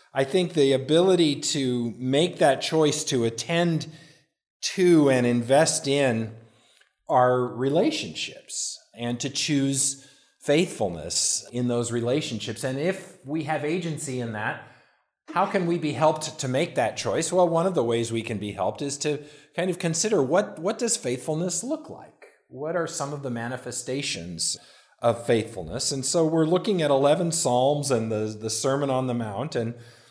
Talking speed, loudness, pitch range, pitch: 165 wpm, -25 LUFS, 120-160 Hz, 140 Hz